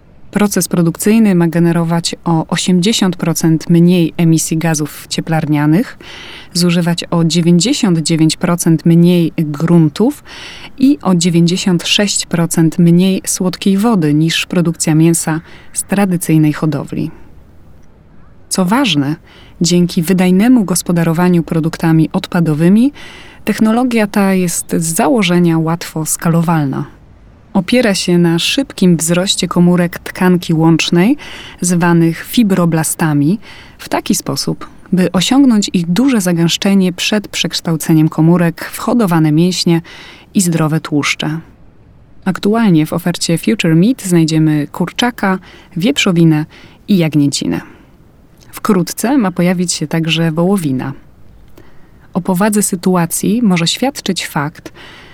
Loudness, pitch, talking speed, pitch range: -13 LUFS, 175 Hz, 100 wpm, 160-190 Hz